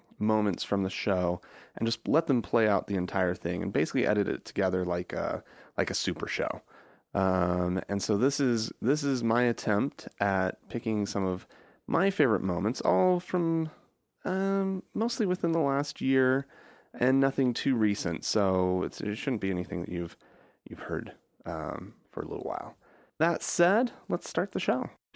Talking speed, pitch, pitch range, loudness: 175 wpm, 110 Hz, 95-140 Hz, -29 LUFS